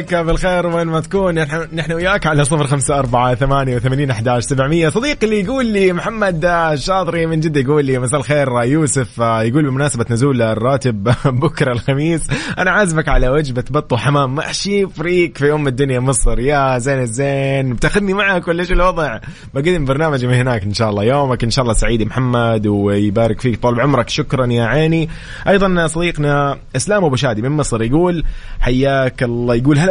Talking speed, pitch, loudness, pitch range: 175 wpm, 140 Hz, -15 LUFS, 125-165 Hz